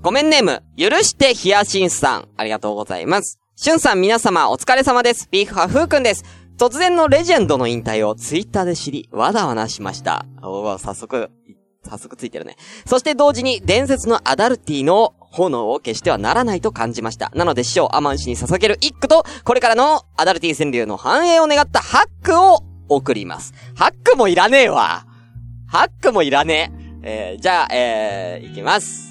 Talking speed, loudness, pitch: 390 characters per minute, -16 LUFS, 185 Hz